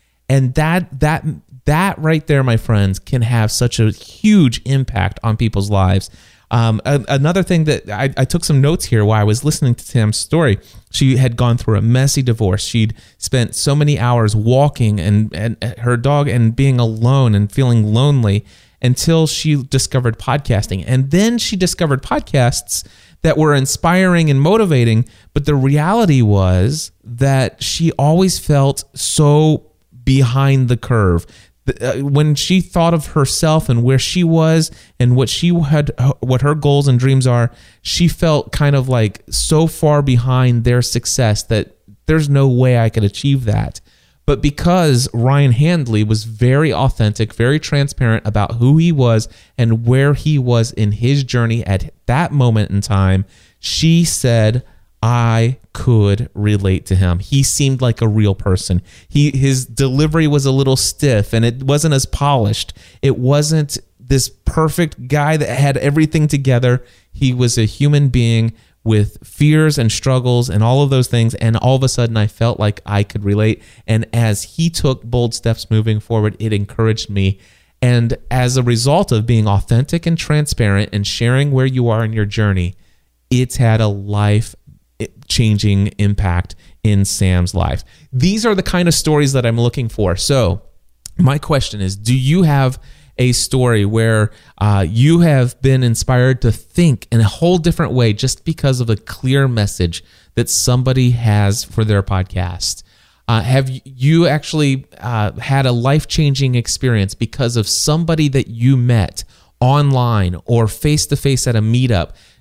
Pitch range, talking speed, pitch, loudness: 110-140 Hz, 165 wpm, 125 Hz, -15 LUFS